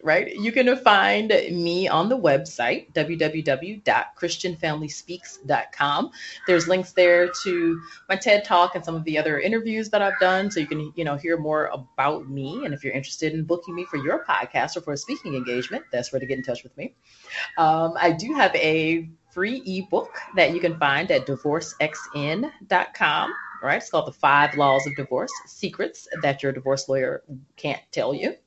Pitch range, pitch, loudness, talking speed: 140-180 Hz, 160 Hz, -23 LUFS, 180 wpm